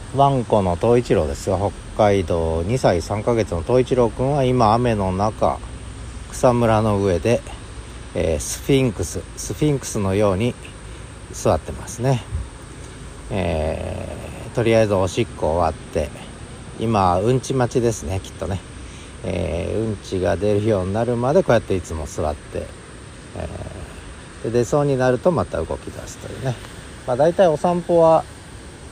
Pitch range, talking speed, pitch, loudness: 90-120 Hz, 290 characters per minute, 105 Hz, -20 LUFS